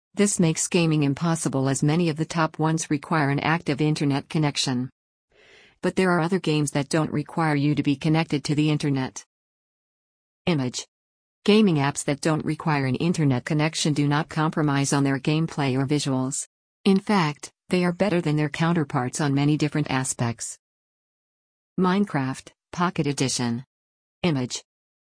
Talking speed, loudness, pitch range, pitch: 150 wpm, -24 LUFS, 140-160 Hz, 150 Hz